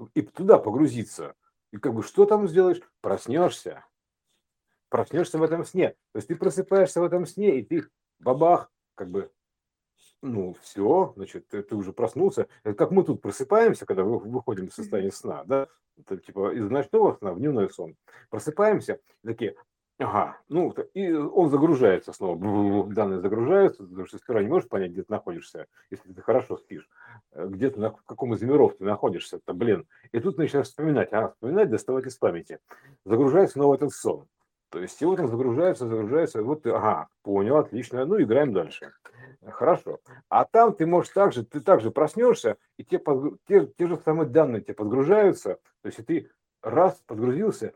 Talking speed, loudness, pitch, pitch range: 170 wpm, -24 LUFS, 170 Hz, 130-200 Hz